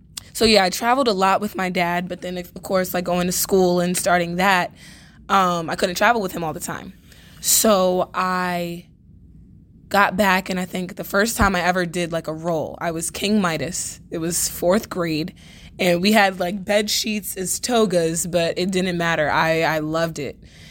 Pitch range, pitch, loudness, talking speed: 170-195 Hz, 180 Hz, -20 LUFS, 200 wpm